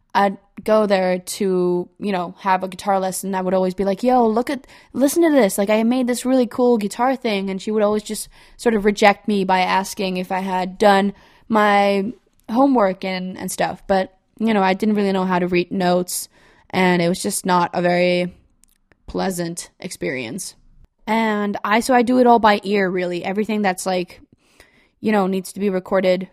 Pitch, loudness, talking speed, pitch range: 200 Hz, -19 LUFS, 200 wpm, 185-215 Hz